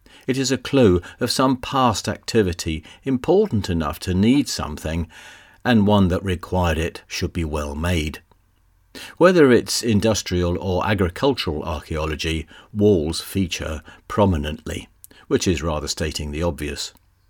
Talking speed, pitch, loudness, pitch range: 130 wpm, 90 Hz, -21 LUFS, 80-105 Hz